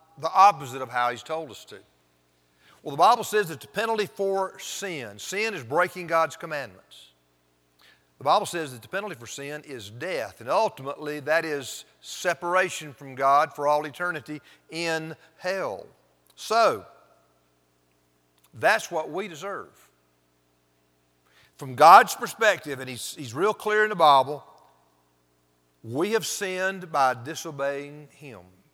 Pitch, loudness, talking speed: 140 Hz, -24 LUFS, 140 wpm